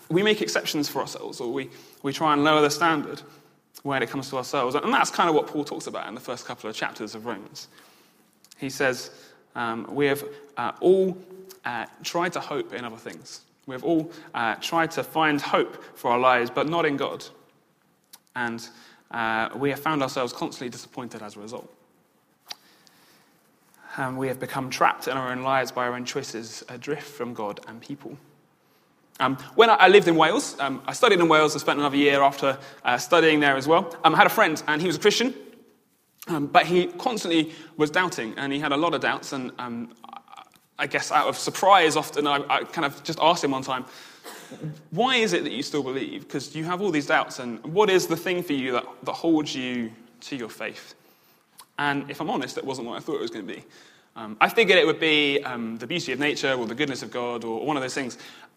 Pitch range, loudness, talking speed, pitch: 125-160 Hz, -24 LUFS, 220 wpm, 145 Hz